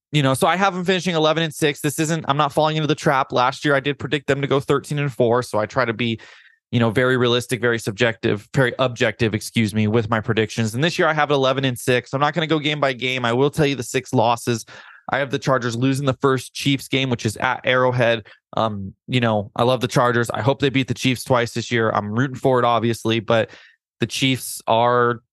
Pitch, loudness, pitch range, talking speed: 130 Hz, -20 LUFS, 115-140 Hz, 255 wpm